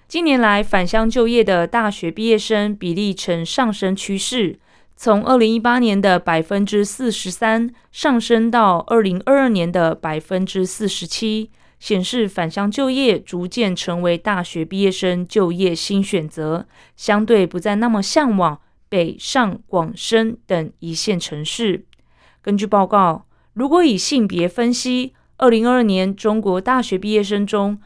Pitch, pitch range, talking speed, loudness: 205 Hz, 180-230 Hz, 210 characters per minute, -18 LUFS